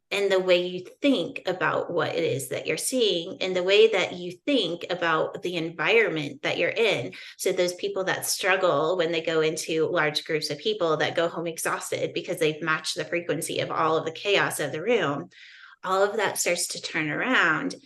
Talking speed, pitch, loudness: 205 wpm, 180 Hz, -25 LUFS